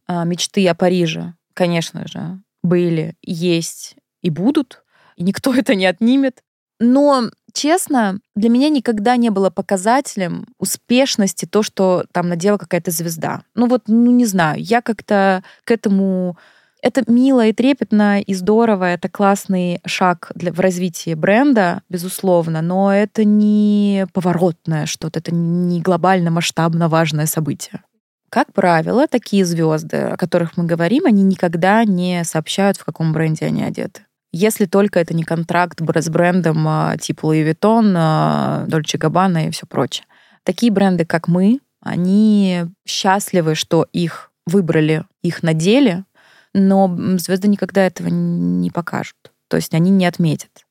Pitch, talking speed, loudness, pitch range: 185 Hz, 140 wpm, -16 LUFS, 170-210 Hz